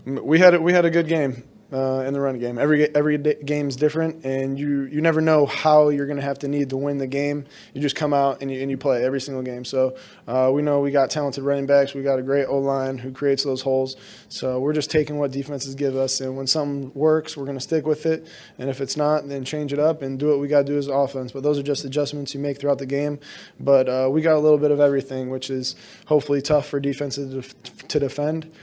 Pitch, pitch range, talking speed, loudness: 140 Hz, 135-150 Hz, 265 wpm, -22 LUFS